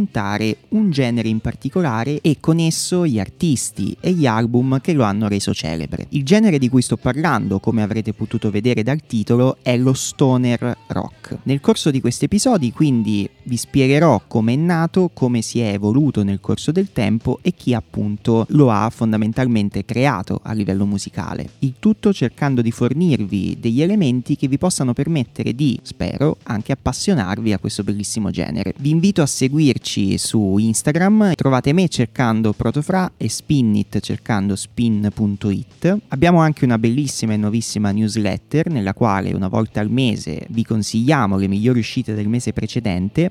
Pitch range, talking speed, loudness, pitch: 105-145 Hz, 160 wpm, -18 LUFS, 120 Hz